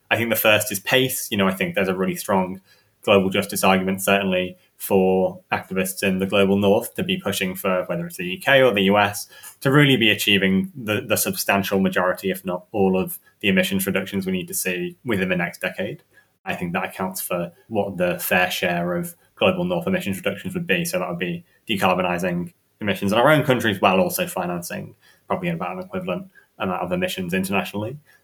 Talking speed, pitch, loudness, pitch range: 200 wpm, 100 Hz, -21 LUFS, 95-135 Hz